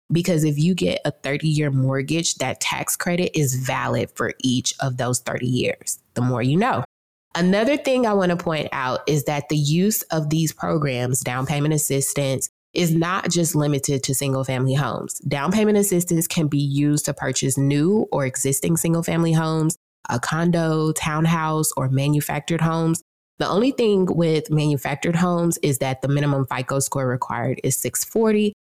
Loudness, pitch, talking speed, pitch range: -21 LUFS, 150 Hz, 170 wpm, 135-170 Hz